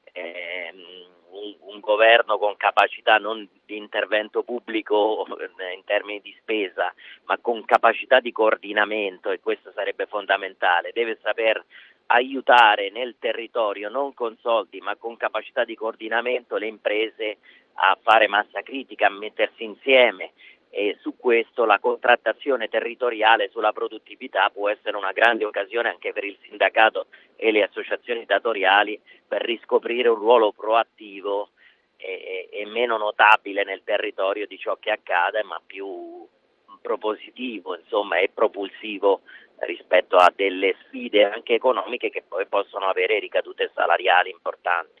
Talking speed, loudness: 130 wpm, -22 LUFS